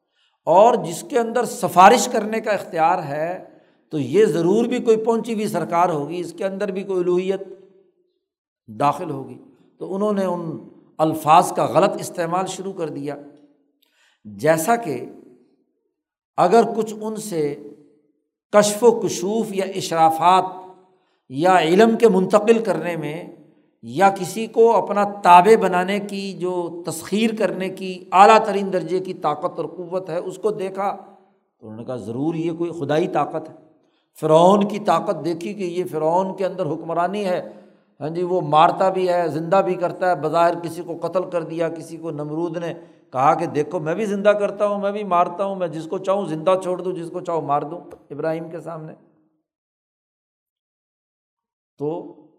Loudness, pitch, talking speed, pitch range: -20 LUFS, 180 Hz, 165 wpm, 160-200 Hz